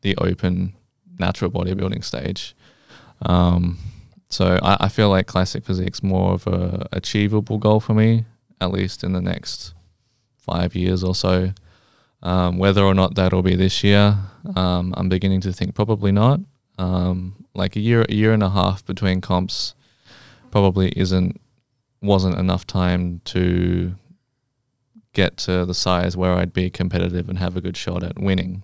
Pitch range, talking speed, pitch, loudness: 90-105 Hz, 160 wpm, 95 Hz, -20 LUFS